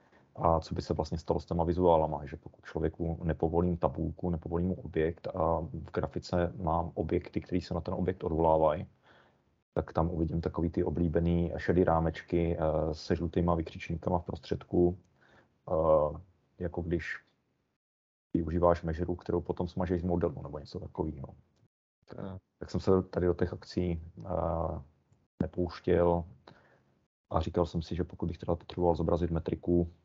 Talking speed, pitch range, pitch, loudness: 140 wpm, 80-90 Hz, 85 Hz, -32 LUFS